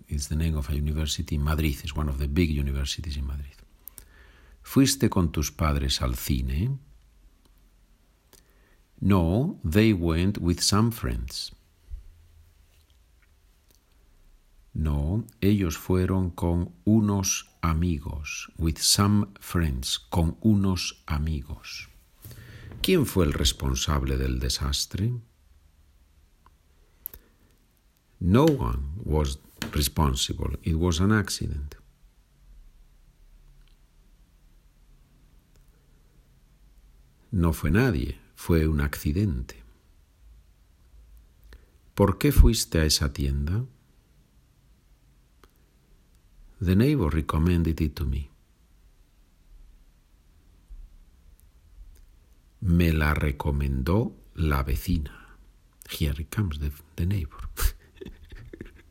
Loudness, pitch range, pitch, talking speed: -26 LUFS, 75-90 Hz, 80 Hz, 85 wpm